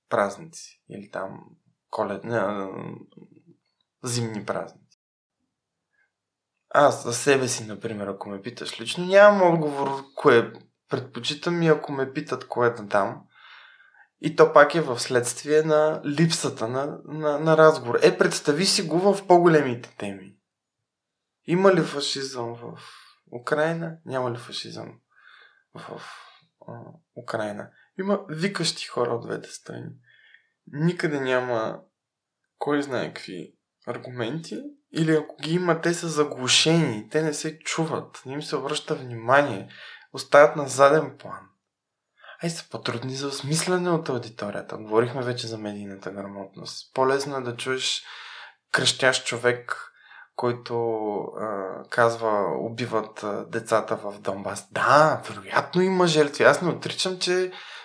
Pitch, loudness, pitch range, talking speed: 140 Hz, -23 LUFS, 120-160 Hz, 130 wpm